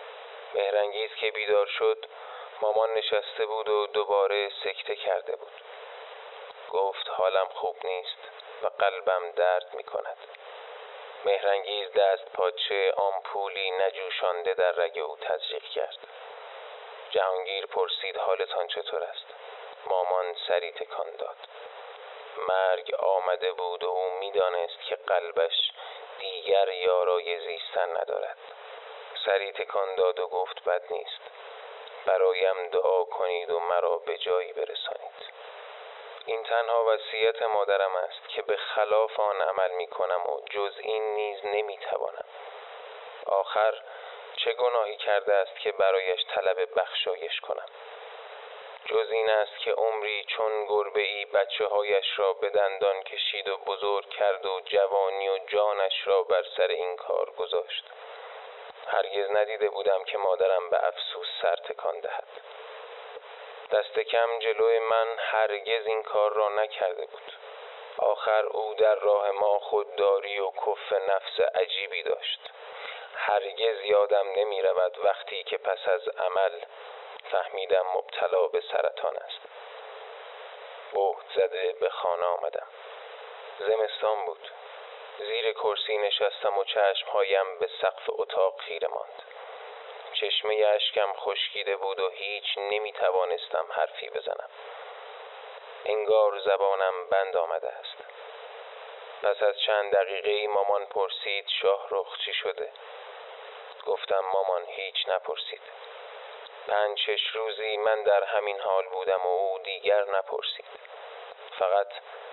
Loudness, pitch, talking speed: -28 LUFS, 125 Hz, 120 wpm